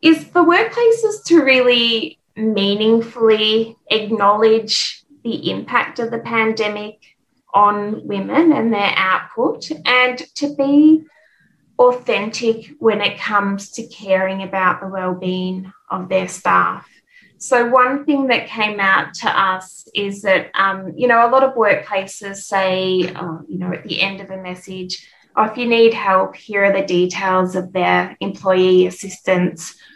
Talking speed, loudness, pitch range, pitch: 145 wpm, -16 LUFS, 190-240 Hz, 210 Hz